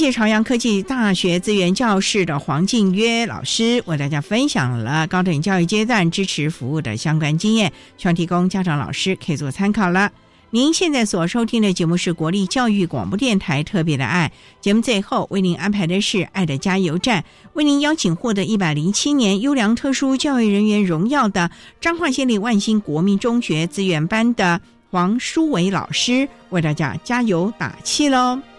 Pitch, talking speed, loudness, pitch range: 195 Hz, 290 characters per minute, -18 LUFS, 170-230 Hz